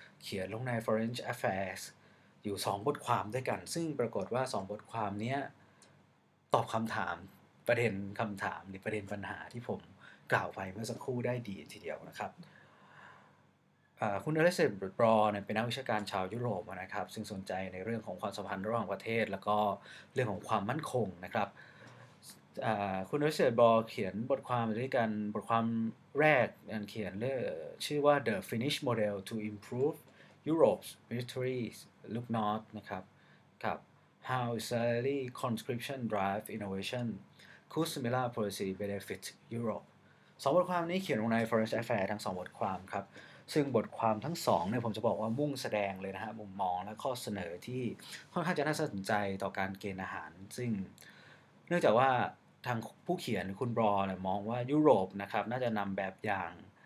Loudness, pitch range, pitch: -35 LUFS, 100-125 Hz, 110 Hz